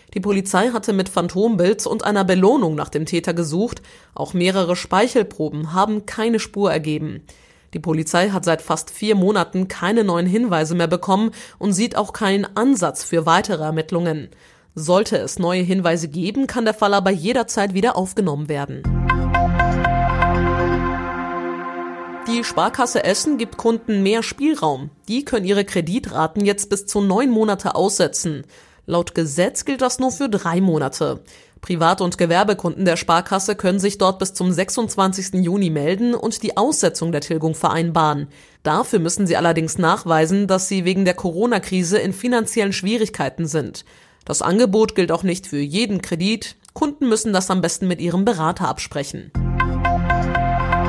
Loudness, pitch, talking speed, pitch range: -19 LUFS, 185 Hz, 150 wpm, 165-210 Hz